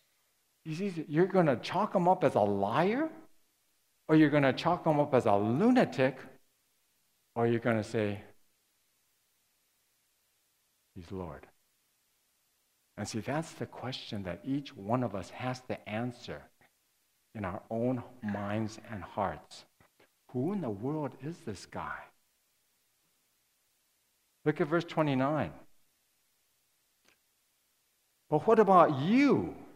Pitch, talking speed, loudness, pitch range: 125 Hz, 120 wpm, -30 LUFS, 105-155 Hz